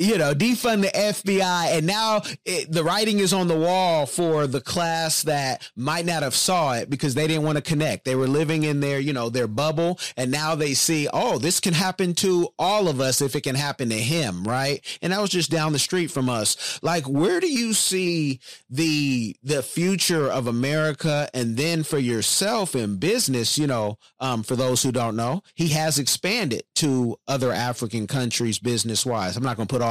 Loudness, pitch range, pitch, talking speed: -22 LUFS, 130-170 Hz, 150 Hz, 210 wpm